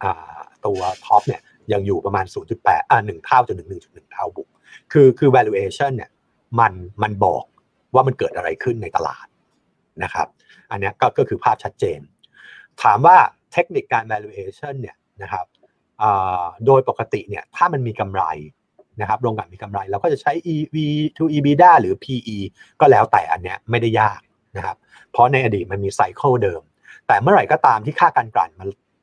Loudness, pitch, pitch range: -18 LUFS, 130 Hz, 105-180 Hz